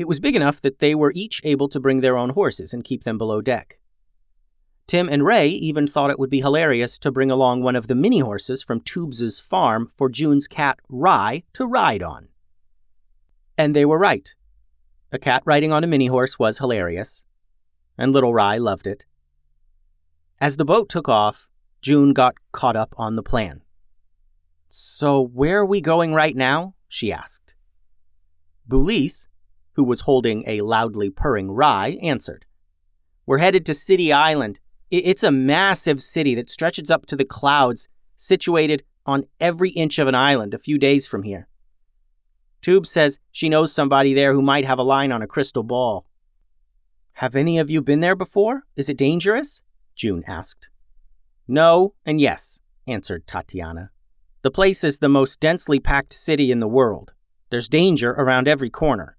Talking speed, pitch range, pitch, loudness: 170 wpm, 90-150 Hz, 135 Hz, -19 LUFS